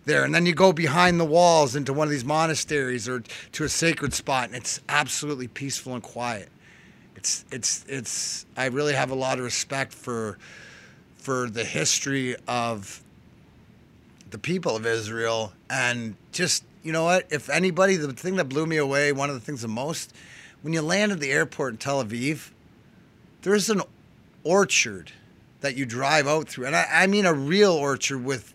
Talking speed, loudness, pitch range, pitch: 185 wpm, -24 LUFS, 125-160 Hz, 140 Hz